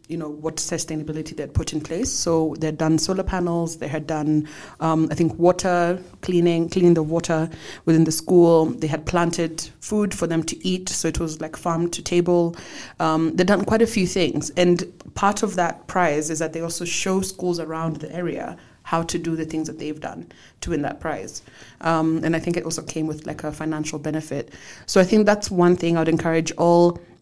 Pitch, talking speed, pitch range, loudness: 165 Hz, 215 wpm, 160-175 Hz, -22 LUFS